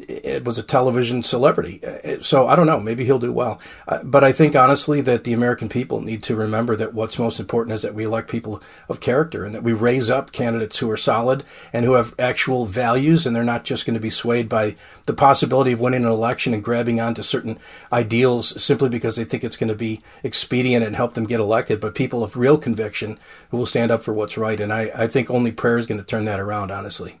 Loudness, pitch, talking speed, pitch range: -19 LUFS, 115 Hz, 240 wpm, 110-125 Hz